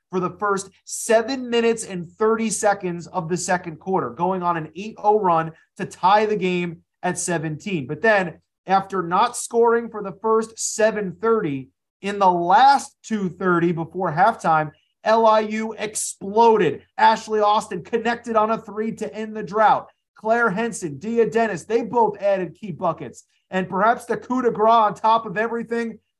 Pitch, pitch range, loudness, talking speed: 210 Hz, 180-225 Hz, -21 LUFS, 160 wpm